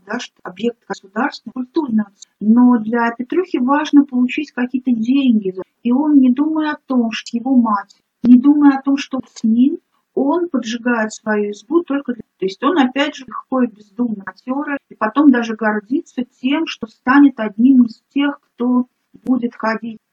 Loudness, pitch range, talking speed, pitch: -17 LUFS, 230-280 Hz, 160 wpm, 250 Hz